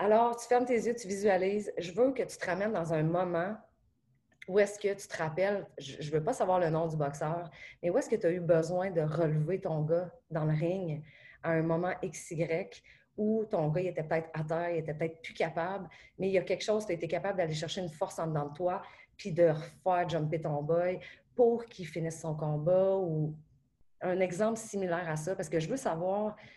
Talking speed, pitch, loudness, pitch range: 235 wpm, 175 Hz, -32 LUFS, 160-195 Hz